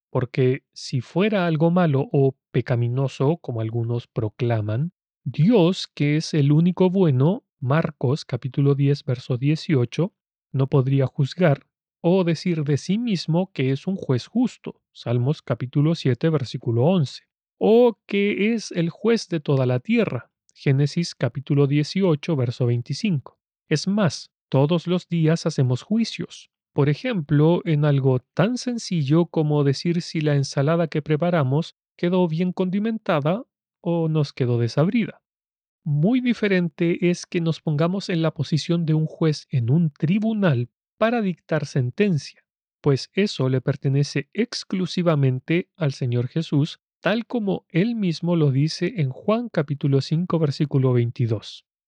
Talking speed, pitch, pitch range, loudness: 135 wpm, 155 Hz, 140-180 Hz, -22 LUFS